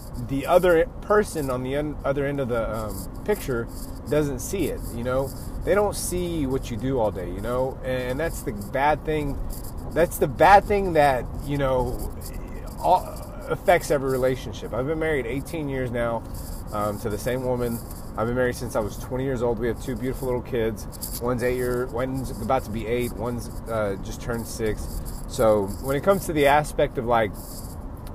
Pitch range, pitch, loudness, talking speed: 110-140 Hz, 125 Hz, -25 LUFS, 190 wpm